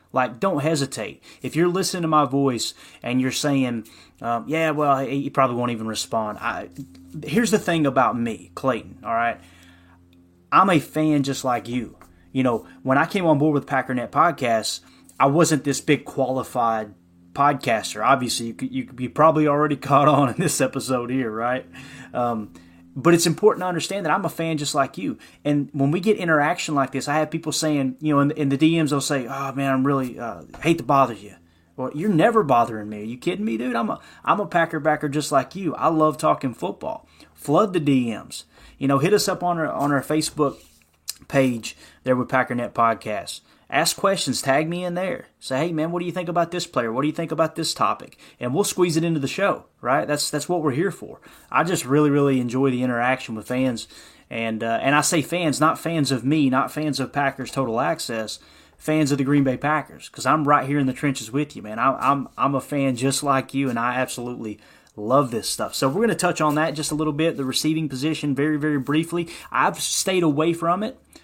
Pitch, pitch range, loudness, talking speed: 140 Hz, 125-155 Hz, -22 LUFS, 220 wpm